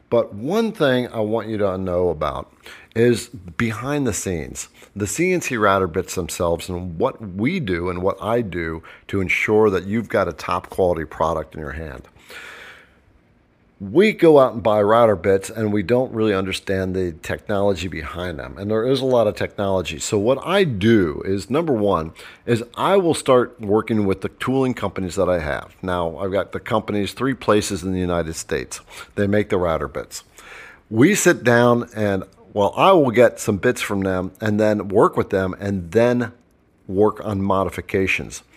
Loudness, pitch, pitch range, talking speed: -20 LUFS, 100 Hz, 95-120 Hz, 185 wpm